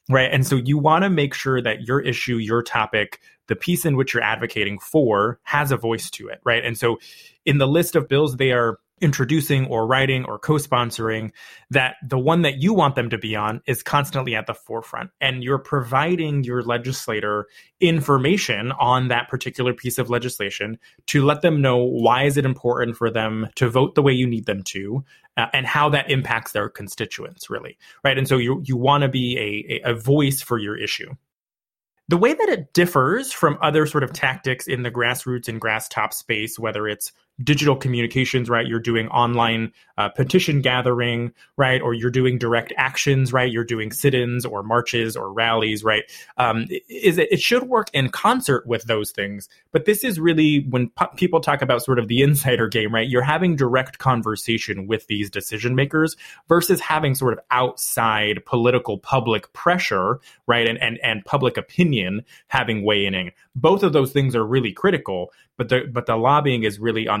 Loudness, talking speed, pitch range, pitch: -20 LUFS, 195 wpm, 115-140 Hz, 125 Hz